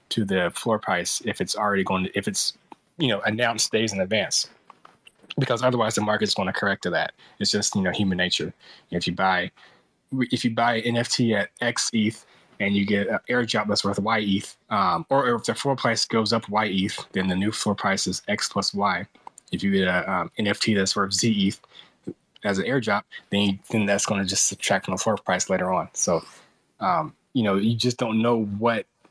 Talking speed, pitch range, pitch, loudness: 220 wpm, 100-115 Hz, 105 Hz, -24 LUFS